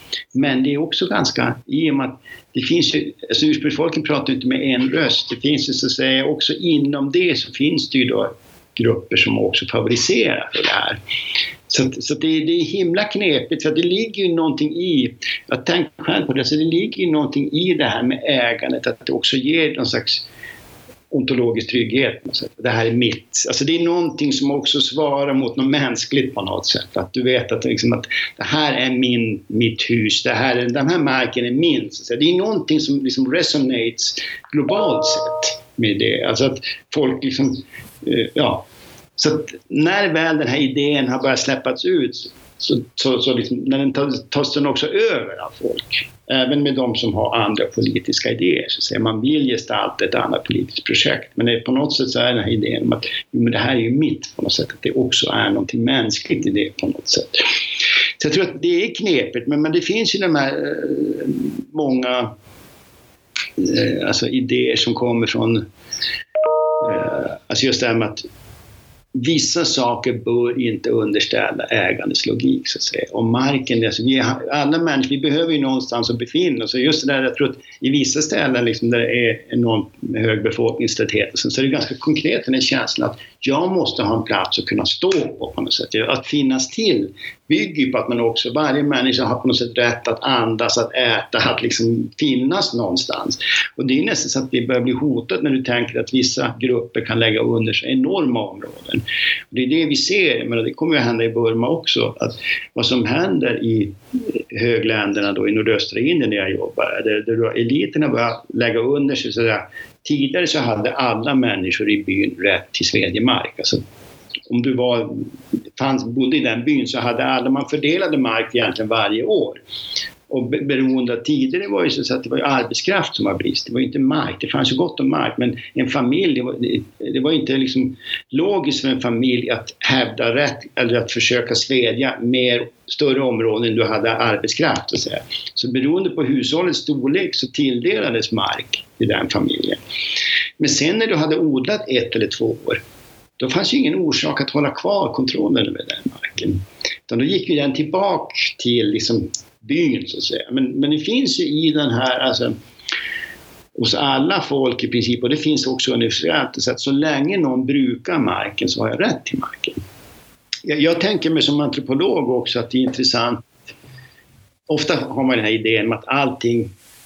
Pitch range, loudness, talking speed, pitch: 120-175 Hz, -18 LUFS, 195 wpm, 135 Hz